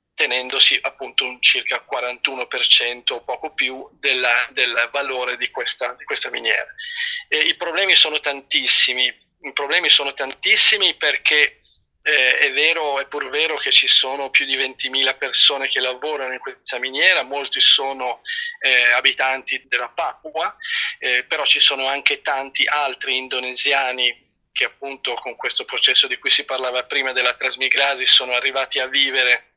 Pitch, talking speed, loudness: 140 Hz, 145 wpm, -16 LUFS